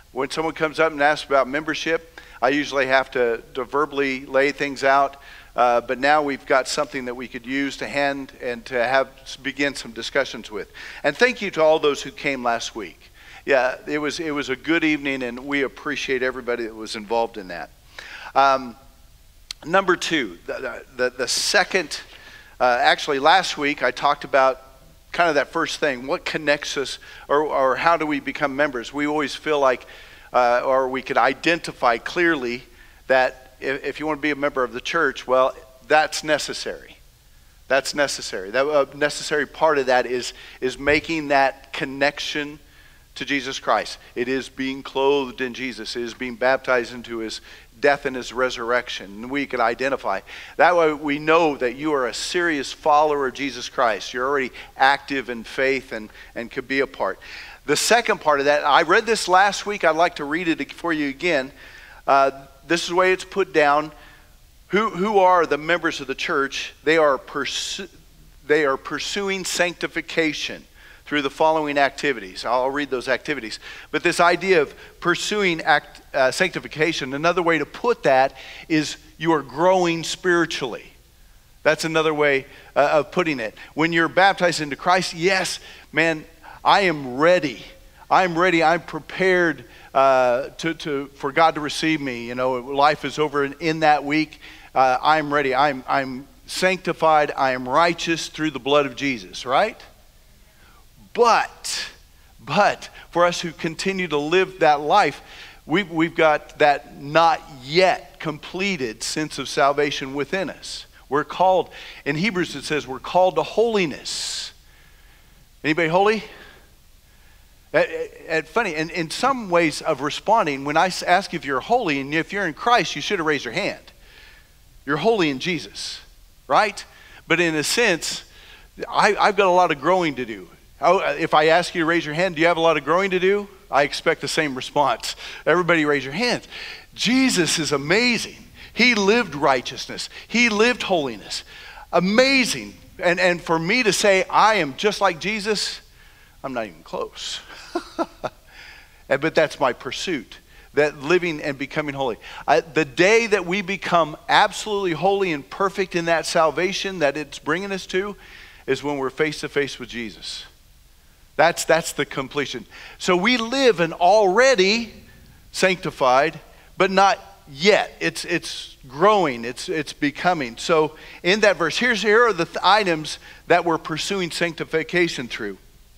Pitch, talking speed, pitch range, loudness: 155 Hz, 170 wpm, 135-175 Hz, -21 LUFS